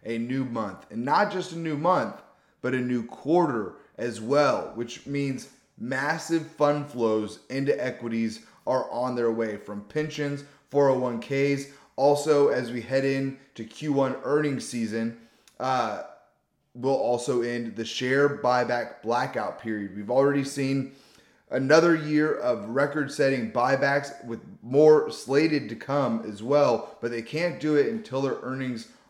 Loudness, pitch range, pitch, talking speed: -26 LUFS, 115-145 Hz, 135 Hz, 145 wpm